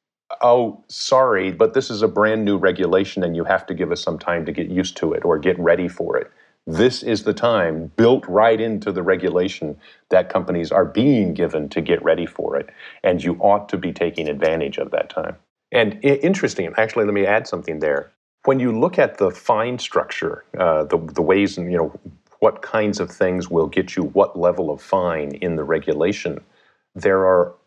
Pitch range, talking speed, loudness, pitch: 90-125 Hz, 205 wpm, -19 LUFS, 100 Hz